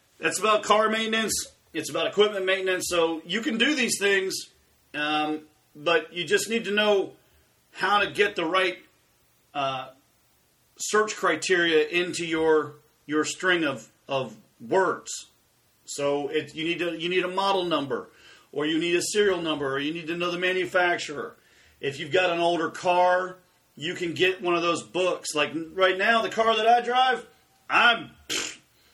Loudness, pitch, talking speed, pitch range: -25 LUFS, 175 Hz, 170 wpm, 155-195 Hz